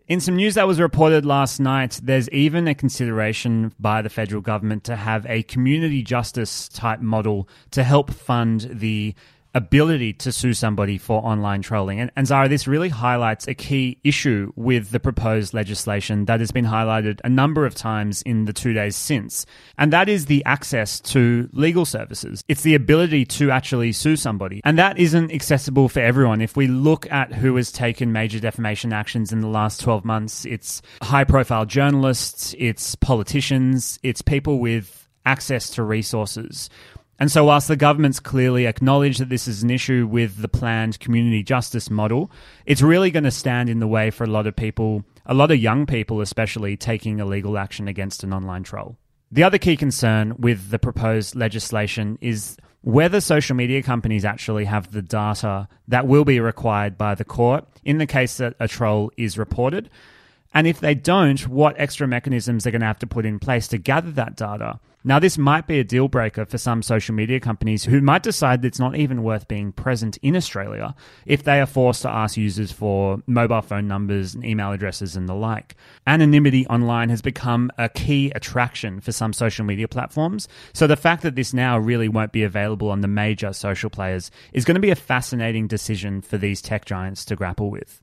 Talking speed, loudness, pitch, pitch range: 195 wpm, -20 LUFS, 120 Hz, 110-135 Hz